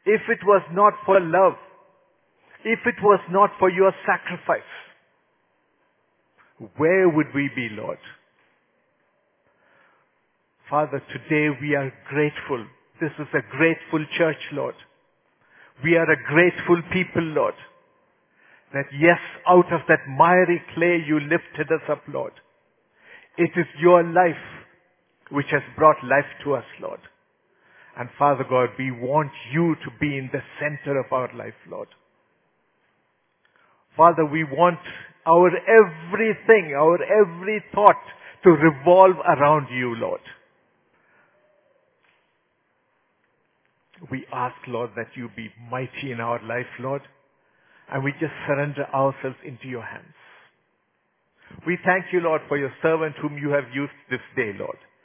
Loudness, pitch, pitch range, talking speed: -21 LUFS, 160 Hz, 140-180 Hz, 130 wpm